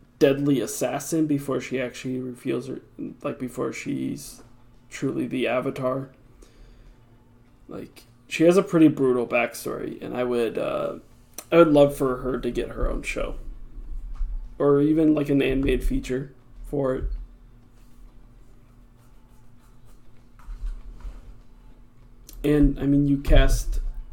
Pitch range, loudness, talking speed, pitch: 120-135 Hz, -24 LUFS, 115 wpm, 125 Hz